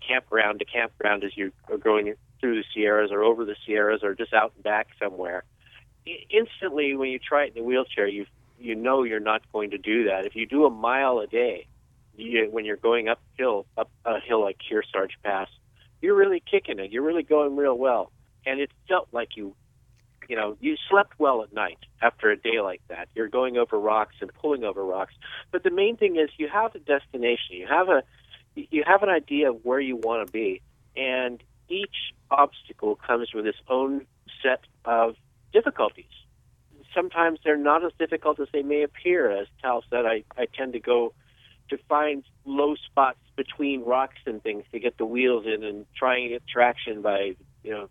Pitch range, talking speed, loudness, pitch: 115-150 Hz, 200 wpm, -25 LUFS, 125 Hz